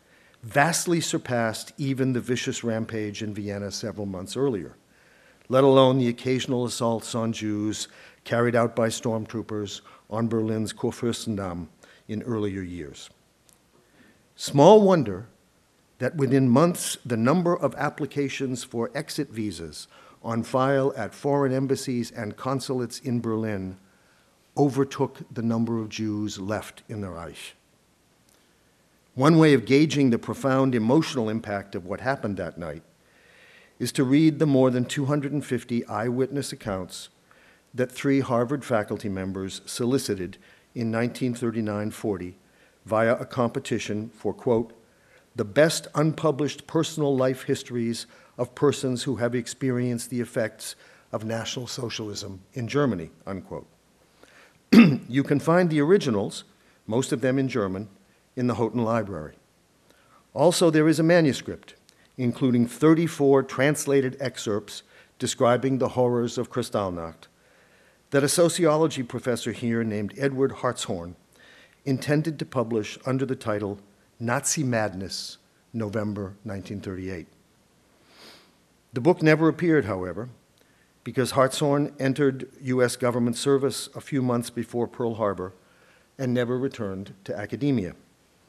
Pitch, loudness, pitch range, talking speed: 120 Hz, -25 LUFS, 110-135 Hz, 125 wpm